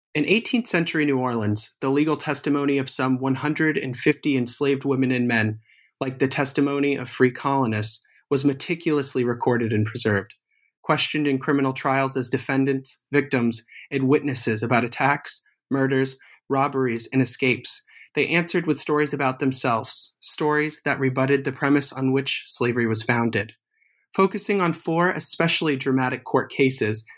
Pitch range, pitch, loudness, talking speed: 125-150 Hz, 135 Hz, -22 LUFS, 140 wpm